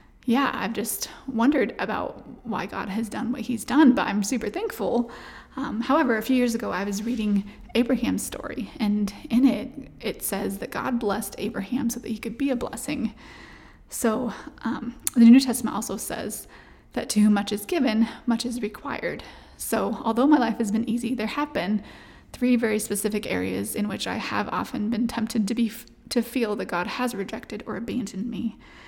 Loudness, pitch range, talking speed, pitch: -25 LUFS, 215-250 Hz, 190 wpm, 235 Hz